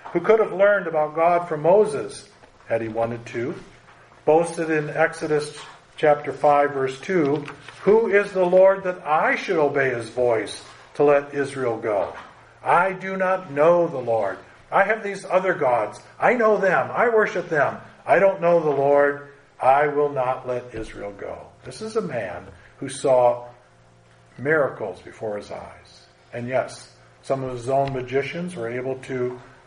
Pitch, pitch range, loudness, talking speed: 145 Hz, 130-180 Hz, -21 LUFS, 165 wpm